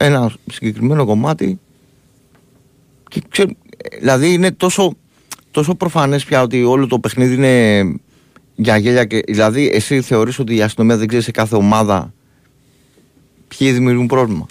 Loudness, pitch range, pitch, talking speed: -14 LUFS, 110-140 Hz, 130 Hz, 135 wpm